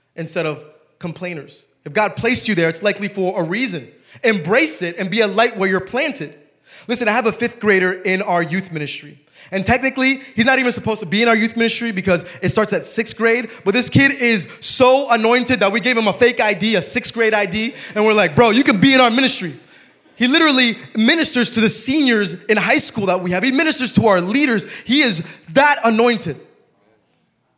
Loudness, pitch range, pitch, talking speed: -14 LUFS, 185-245 Hz, 220 Hz, 215 wpm